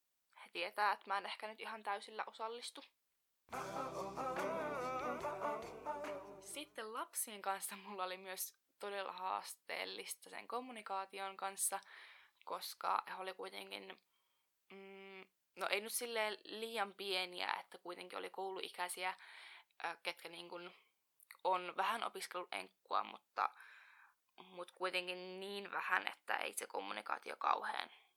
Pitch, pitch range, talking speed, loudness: 195 Hz, 185-220 Hz, 110 wpm, -43 LUFS